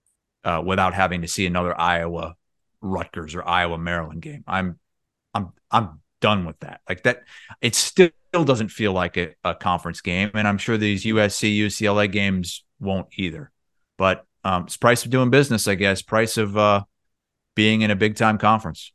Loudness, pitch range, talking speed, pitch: -21 LUFS, 90-110 Hz, 180 wpm, 100 Hz